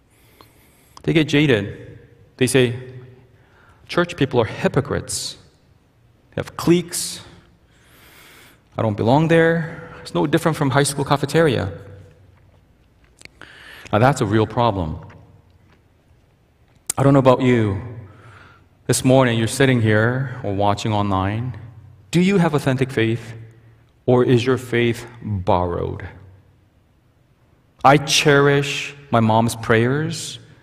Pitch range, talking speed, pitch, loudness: 105-135 Hz, 110 wpm, 120 Hz, -18 LUFS